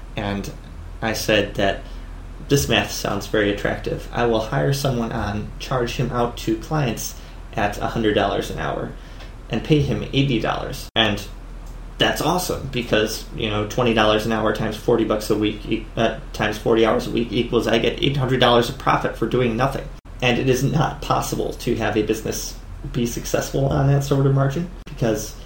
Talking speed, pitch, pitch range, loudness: 170 wpm, 115 Hz, 105-130 Hz, -21 LUFS